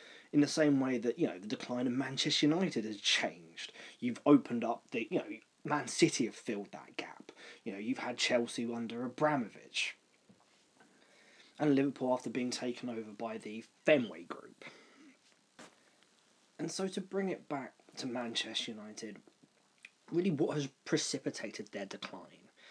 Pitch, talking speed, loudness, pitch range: 130 Hz, 155 wpm, -35 LUFS, 120-150 Hz